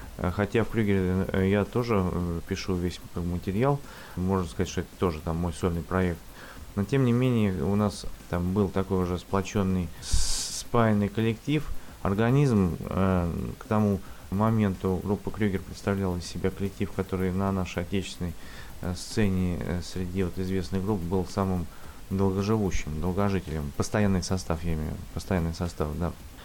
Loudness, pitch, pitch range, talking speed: -28 LUFS, 95 Hz, 90-100 Hz, 140 wpm